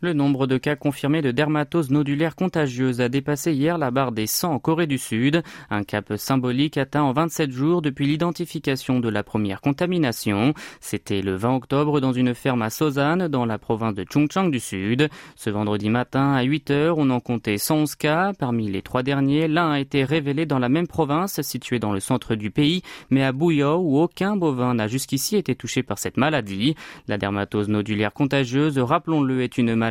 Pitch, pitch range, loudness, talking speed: 140 Hz, 120-155 Hz, -22 LUFS, 195 wpm